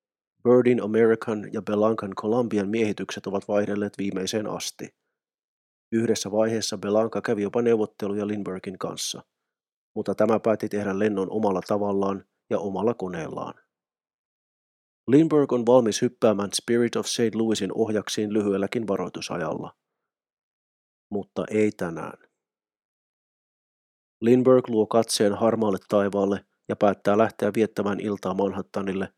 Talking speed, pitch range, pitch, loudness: 110 wpm, 100-115 Hz, 105 Hz, -24 LUFS